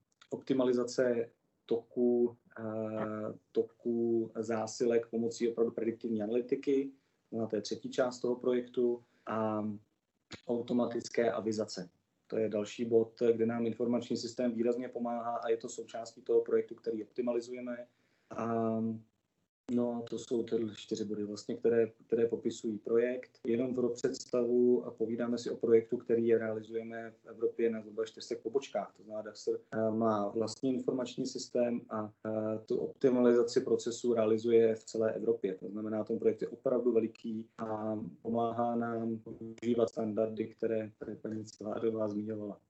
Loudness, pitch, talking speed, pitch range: -34 LUFS, 115 Hz, 130 wpm, 110-120 Hz